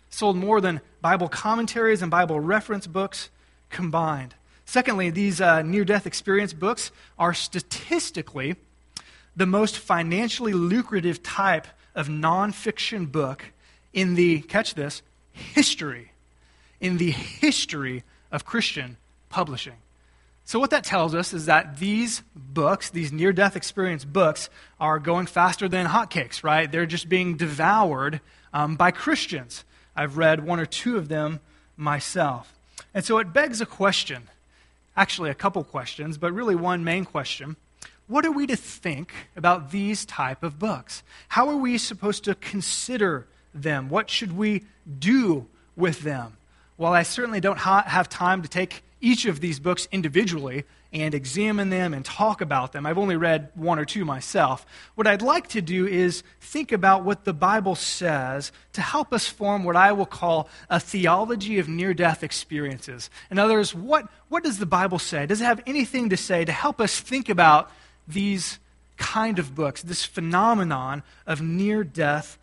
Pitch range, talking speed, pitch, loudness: 155-205 Hz, 155 wpm, 180 Hz, -24 LUFS